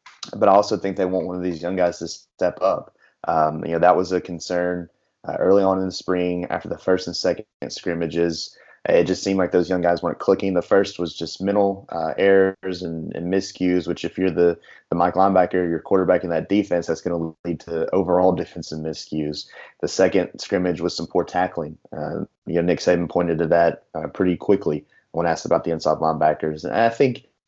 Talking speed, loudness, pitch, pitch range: 215 wpm, -21 LUFS, 90 Hz, 85-95 Hz